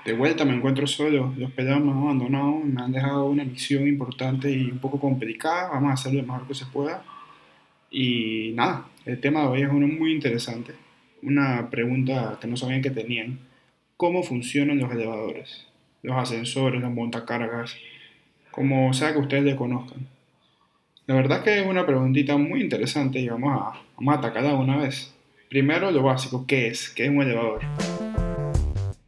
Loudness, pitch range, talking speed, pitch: -24 LUFS, 125-140 Hz, 175 wpm, 135 Hz